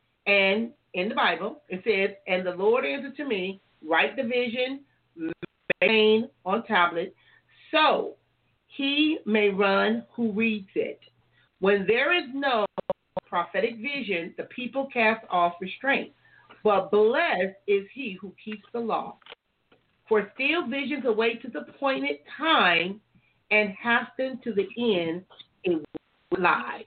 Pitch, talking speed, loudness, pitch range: 215 Hz, 130 wpm, -25 LUFS, 185-250 Hz